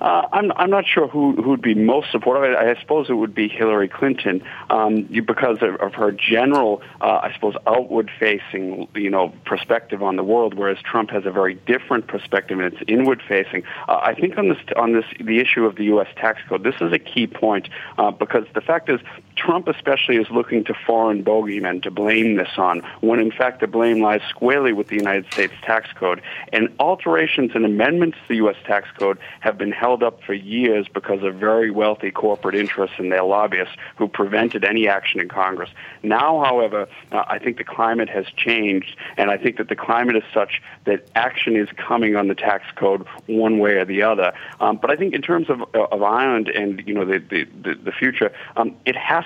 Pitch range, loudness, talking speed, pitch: 100-115 Hz, -19 LUFS, 210 wpm, 110 Hz